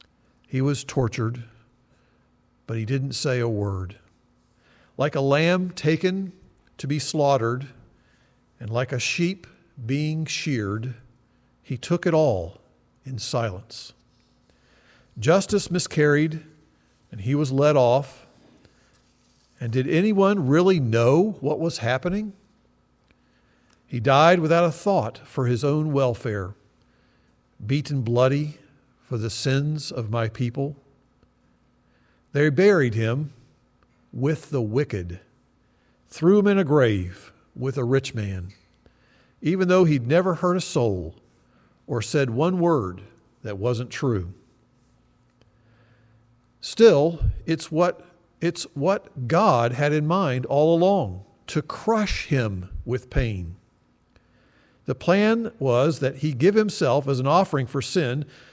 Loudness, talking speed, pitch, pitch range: -23 LUFS, 120 wpm, 135 Hz, 120-160 Hz